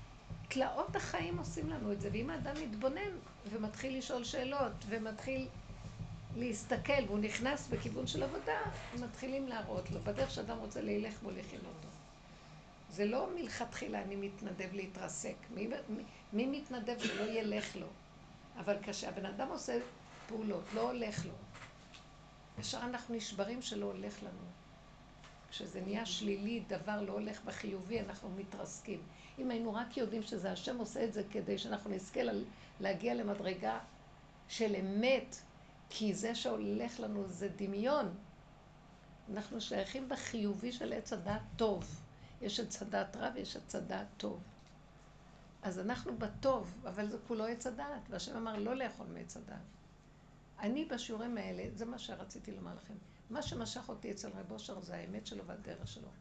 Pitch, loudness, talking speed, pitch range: 210 Hz, -41 LUFS, 145 wpm, 190-235 Hz